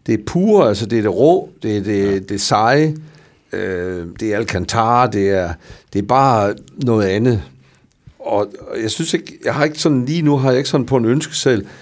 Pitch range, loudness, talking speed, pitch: 100-145 Hz, -16 LUFS, 220 wpm, 115 Hz